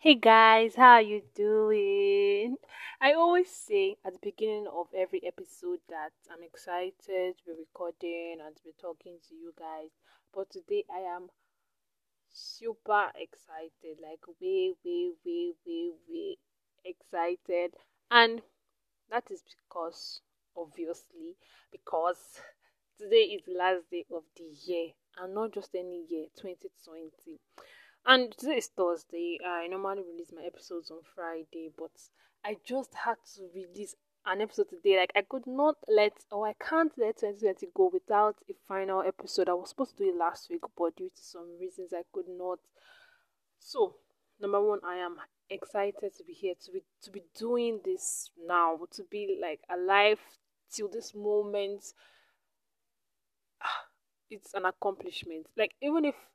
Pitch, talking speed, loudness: 210 Hz, 150 wpm, -30 LUFS